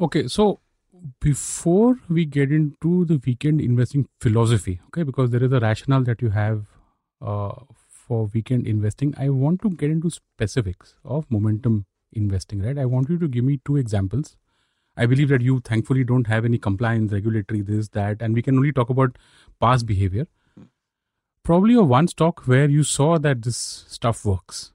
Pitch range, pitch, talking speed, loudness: 110-145 Hz, 125 Hz, 175 wpm, -21 LUFS